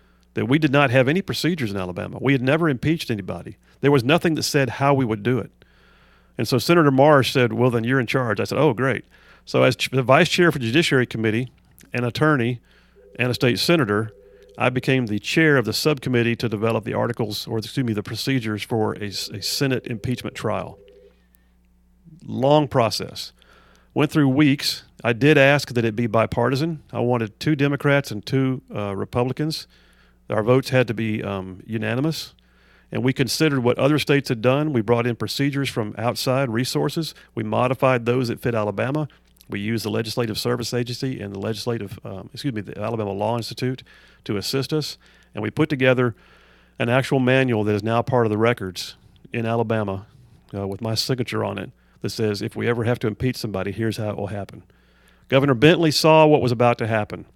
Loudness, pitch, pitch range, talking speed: -21 LUFS, 120 Hz, 105-135 Hz, 190 wpm